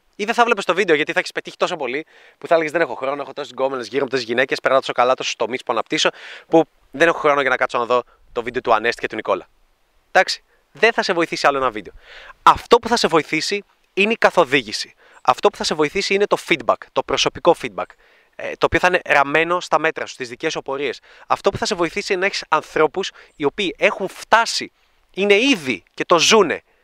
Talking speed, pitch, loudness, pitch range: 235 wpm, 165 Hz, -19 LUFS, 135-200 Hz